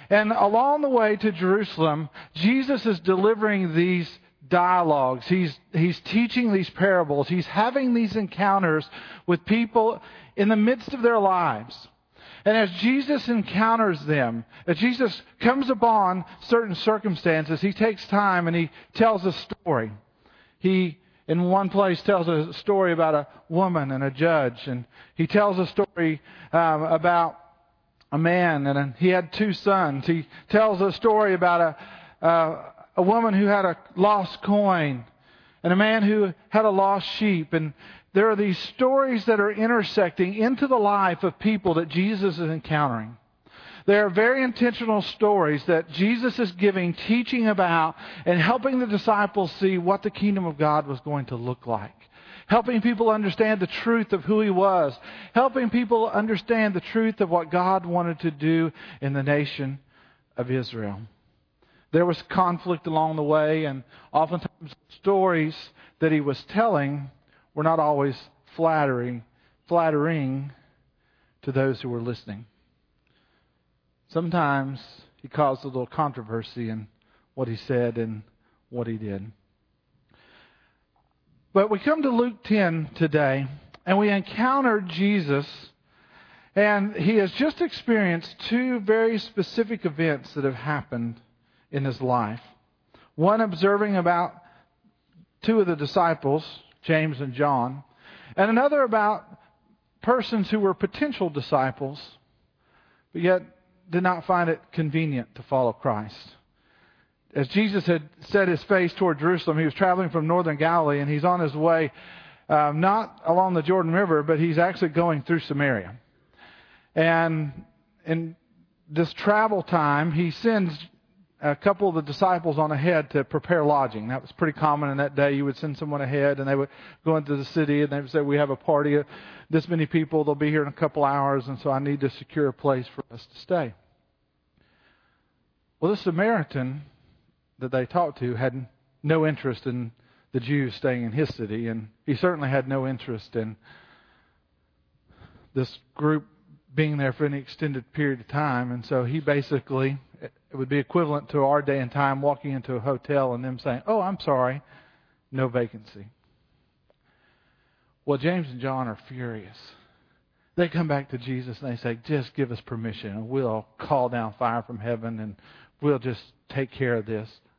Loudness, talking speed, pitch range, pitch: -24 LUFS, 160 wpm, 135-195 Hz, 160 Hz